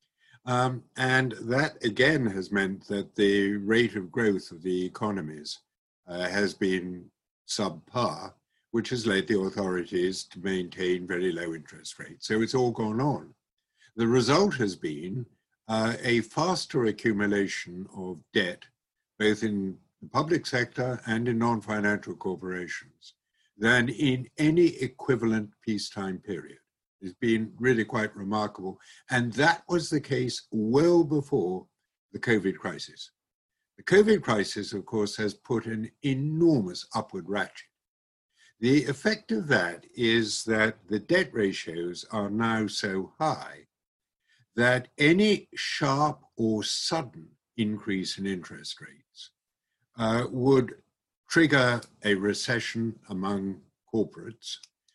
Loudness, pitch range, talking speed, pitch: -27 LUFS, 100-125 Hz, 125 wpm, 110 Hz